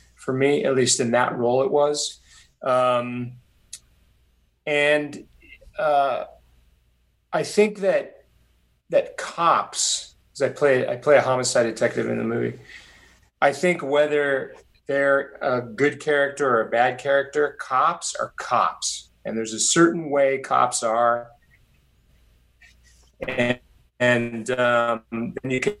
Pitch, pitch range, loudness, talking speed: 125 Hz, 115-145 Hz, -22 LUFS, 130 wpm